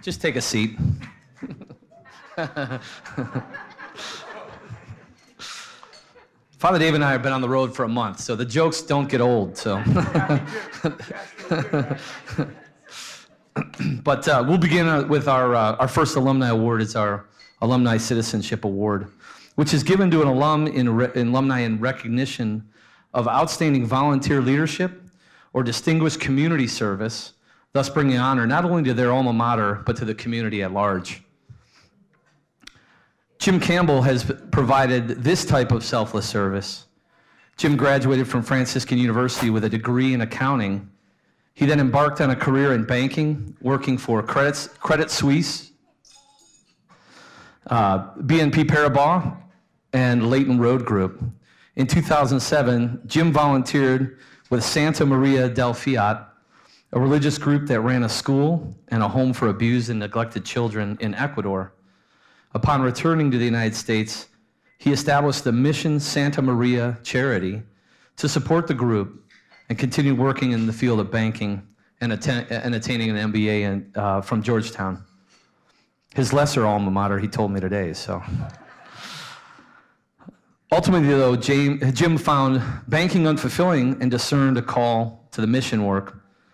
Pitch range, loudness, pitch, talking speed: 115-145 Hz, -21 LUFS, 130 Hz, 135 wpm